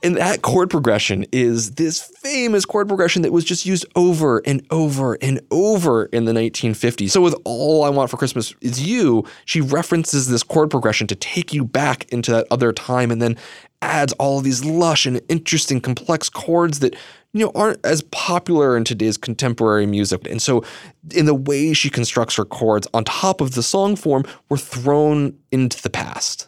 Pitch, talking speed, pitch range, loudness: 140 Hz, 190 wpm, 120-165 Hz, -18 LUFS